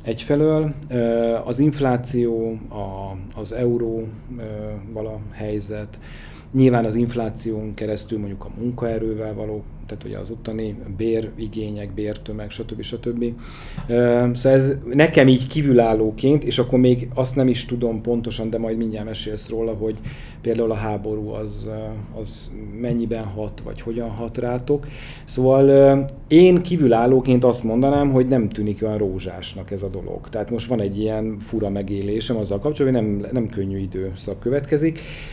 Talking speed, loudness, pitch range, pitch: 140 wpm, -21 LUFS, 105-125 Hz, 115 Hz